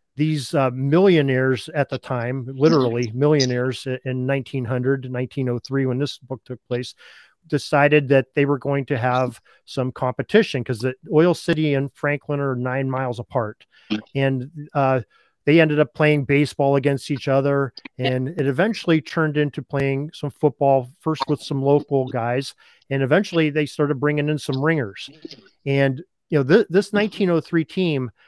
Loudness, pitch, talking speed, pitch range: -21 LUFS, 140 Hz, 155 wpm, 130-150 Hz